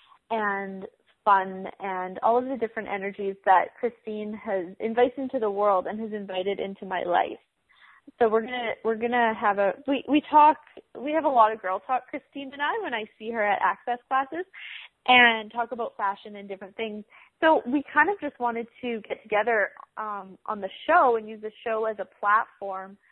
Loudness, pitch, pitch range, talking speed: -25 LUFS, 220 Hz, 200-250 Hz, 195 wpm